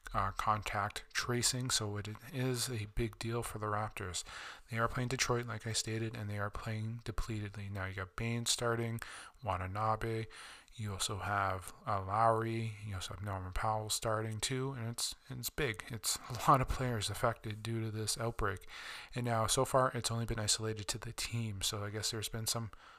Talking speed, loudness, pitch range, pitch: 195 wpm, -37 LUFS, 105-115 Hz, 110 Hz